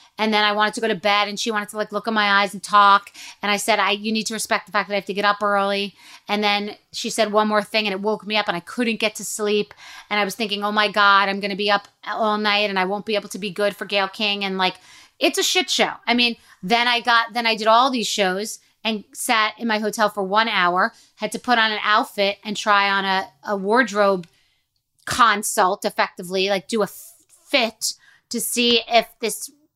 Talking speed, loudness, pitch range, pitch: 255 wpm, -20 LUFS, 200-225 Hz, 210 Hz